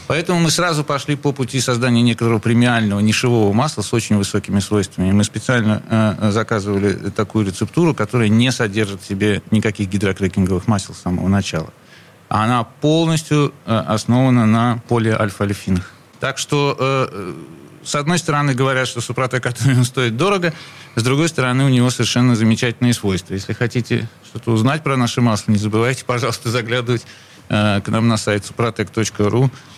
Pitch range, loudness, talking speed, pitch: 105-130 Hz, -17 LUFS, 150 wpm, 120 Hz